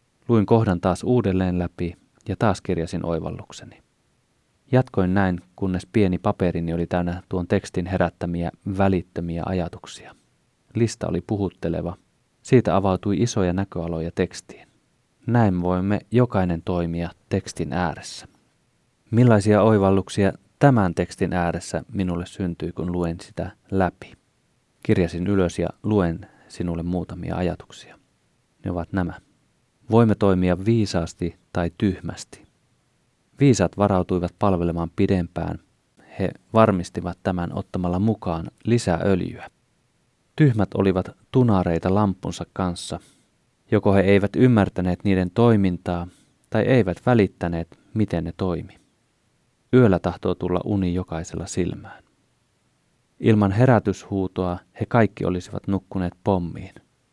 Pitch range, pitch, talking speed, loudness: 90-105 Hz, 95 Hz, 105 wpm, -22 LUFS